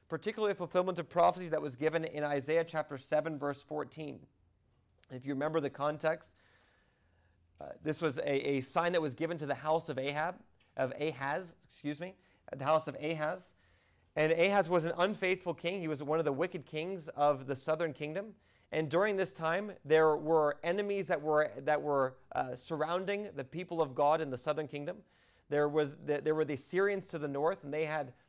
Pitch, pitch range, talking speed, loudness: 155 Hz, 140-170 Hz, 195 wpm, -34 LUFS